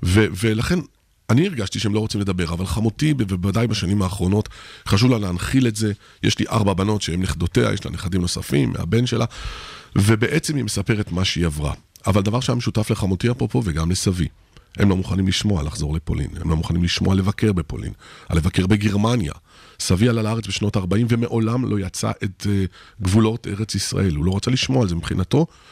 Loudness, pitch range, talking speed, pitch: -21 LUFS, 90-115 Hz, 180 wpm, 100 Hz